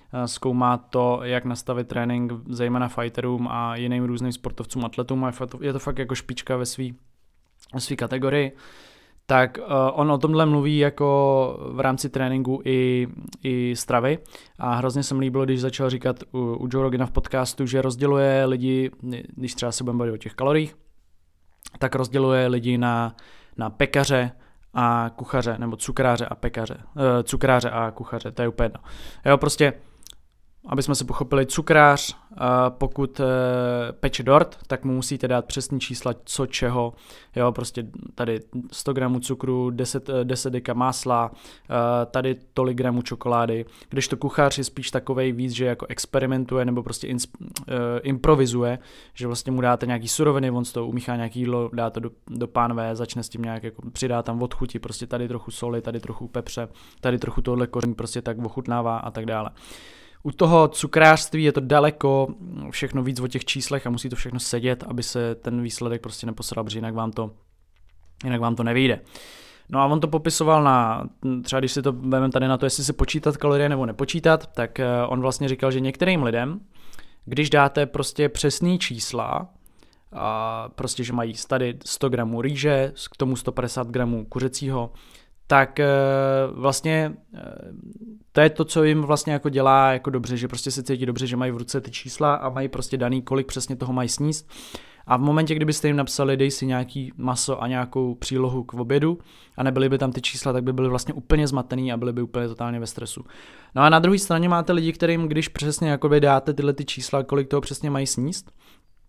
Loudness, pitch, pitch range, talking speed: -23 LUFS, 130 Hz, 120-140 Hz, 180 wpm